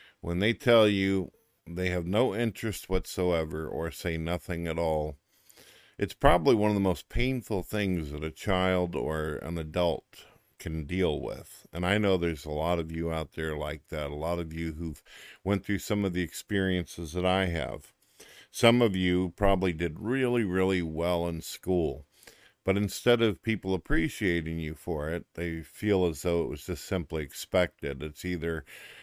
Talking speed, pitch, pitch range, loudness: 180 wpm, 90 Hz, 80-95 Hz, -29 LUFS